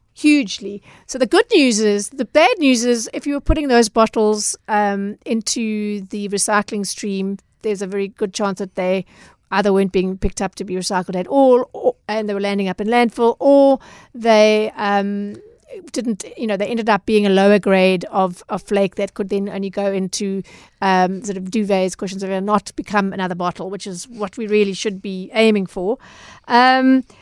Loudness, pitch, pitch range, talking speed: -18 LUFS, 205 Hz, 195-235 Hz, 195 wpm